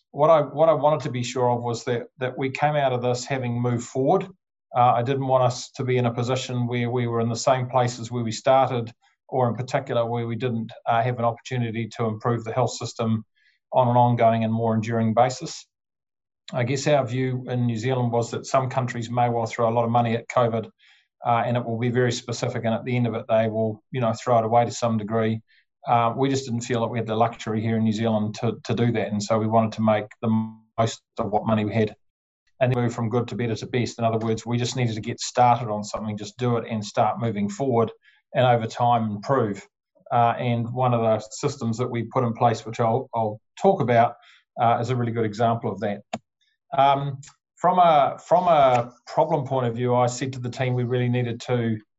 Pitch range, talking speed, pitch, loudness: 115-125 Hz, 240 wpm, 120 Hz, -23 LUFS